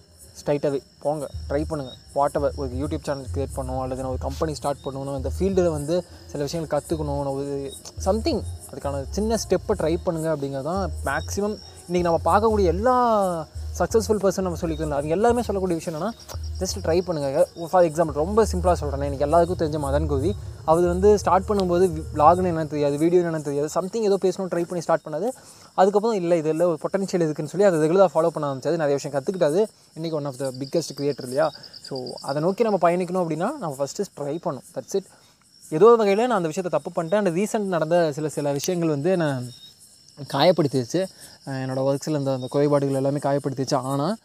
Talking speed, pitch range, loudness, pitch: 180 wpm, 140-185 Hz, -23 LUFS, 160 Hz